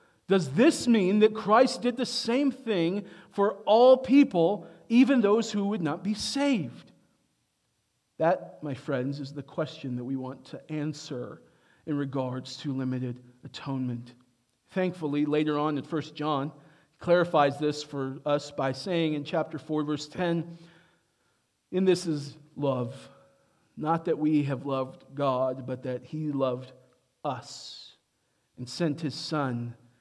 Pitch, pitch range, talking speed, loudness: 150 Hz, 130-175 Hz, 145 wpm, -28 LUFS